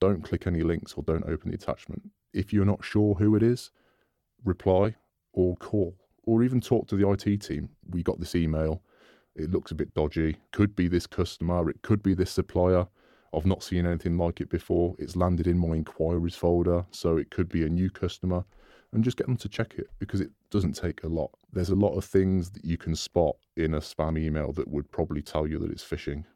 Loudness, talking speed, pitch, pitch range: -28 LUFS, 225 wpm, 90 Hz, 80-100 Hz